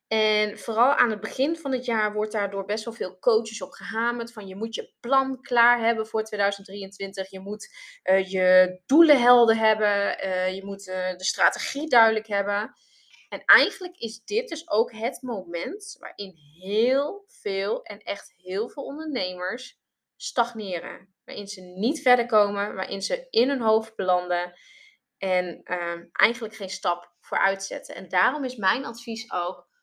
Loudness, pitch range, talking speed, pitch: -25 LUFS, 190-245 Hz, 165 wpm, 215 Hz